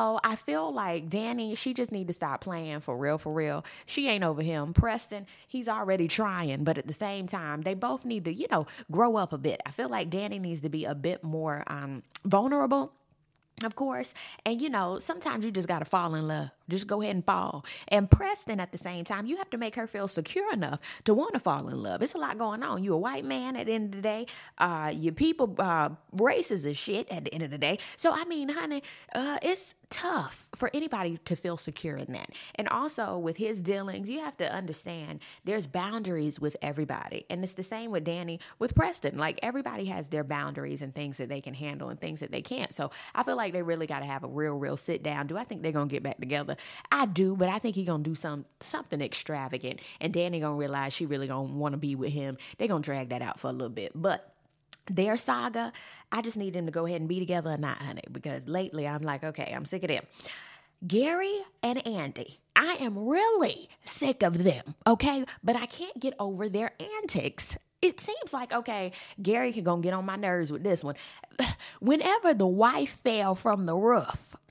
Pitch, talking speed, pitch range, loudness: 185 Hz, 225 wpm, 155-225 Hz, -31 LUFS